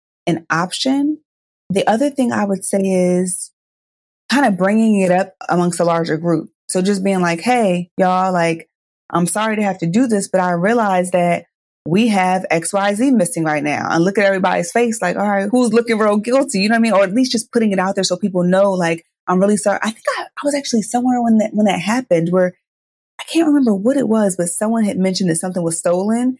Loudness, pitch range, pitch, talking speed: -16 LUFS, 180-230 Hz, 195 Hz, 230 wpm